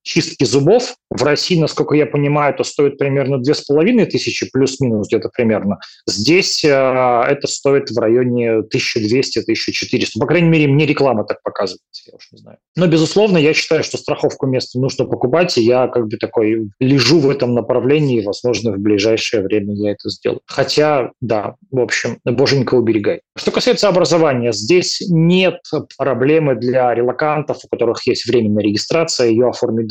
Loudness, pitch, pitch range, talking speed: -15 LUFS, 135 Hz, 120-150 Hz, 165 wpm